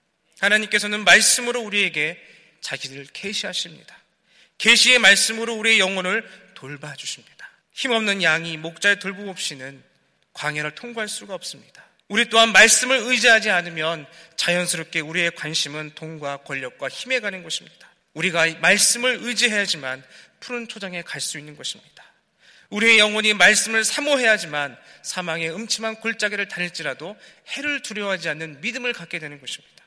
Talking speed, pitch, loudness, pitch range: 360 characters per minute, 195 Hz, -19 LUFS, 160-225 Hz